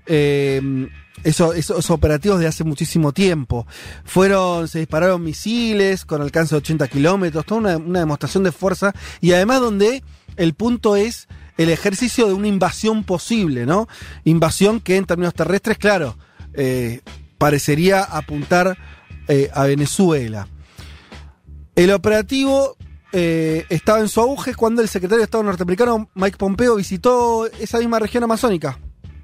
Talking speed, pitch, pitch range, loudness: 140 wpm, 180 Hz, 145-210 Hz, -18 LUFS